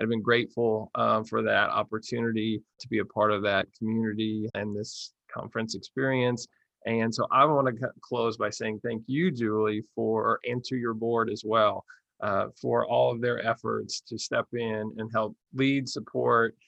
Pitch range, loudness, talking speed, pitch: 110-120 Hz, -28 LUFS, 175 wpm, 115 Hz